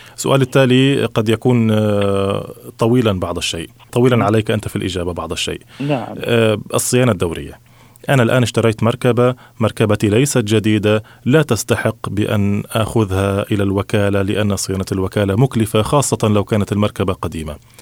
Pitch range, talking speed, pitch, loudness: 100-120 Hz, 130 wpm, 110 Hz, -16 LUFS